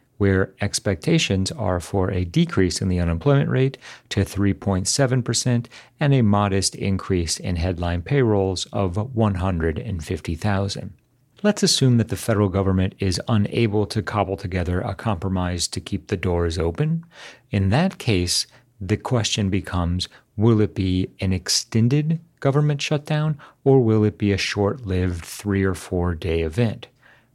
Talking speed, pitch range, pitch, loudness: 140 wpm, 95-125 Hz, 100 Hz, -22 LUFS